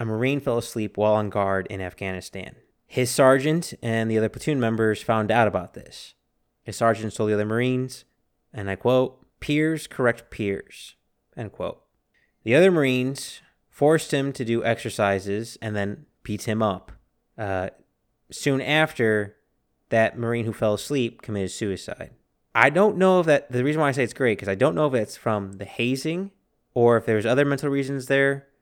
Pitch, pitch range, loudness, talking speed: 115 Hz, 105-140 Hz, -23 LUFS, 180 wpm